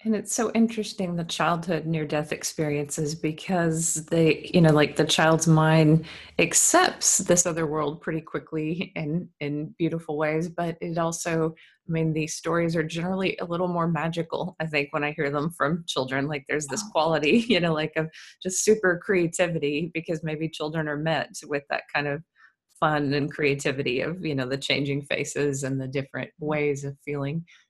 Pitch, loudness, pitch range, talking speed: 160 Hz, -25 LUFS, 150-170 Hz, 180 wpm